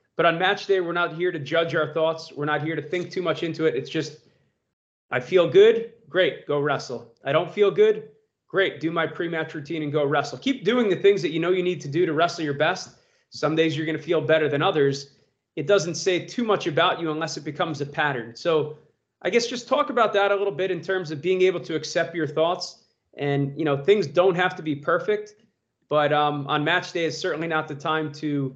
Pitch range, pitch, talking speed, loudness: 155-185 Hz, 165 Hz, 240 wpm, -23 LUFS